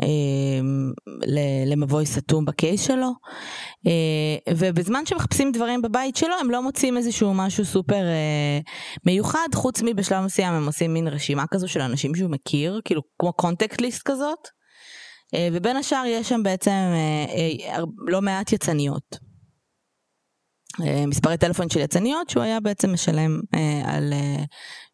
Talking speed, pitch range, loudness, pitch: 120 wpm, 150-230 Hz, -23 LUFS, 175 Hz